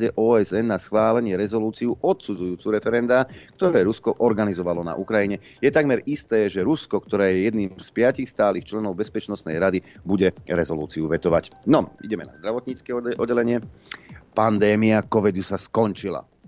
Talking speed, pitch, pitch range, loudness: 135 wpm, 105 Hz, 95-115 Hz, -22 LUFS